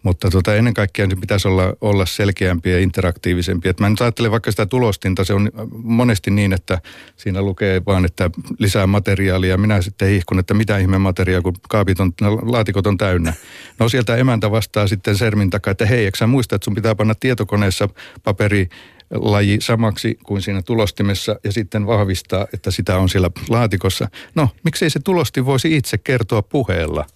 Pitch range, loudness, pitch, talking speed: 95-115 Hz, -17 LUFS, 105 Hz, 175 wpm